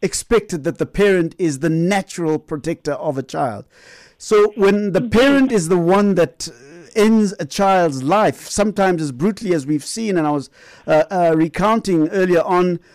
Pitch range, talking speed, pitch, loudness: 160-205 Hz, 170 wpm, 180 Hz, -17 LUFS